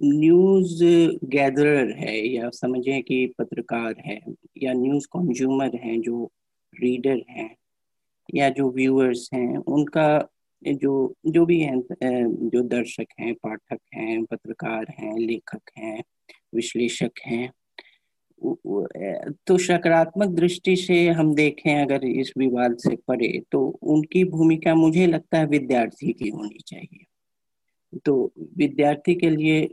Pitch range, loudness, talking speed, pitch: 125-165 Hz, -22 LUFS, 125 wpm, 140 Hz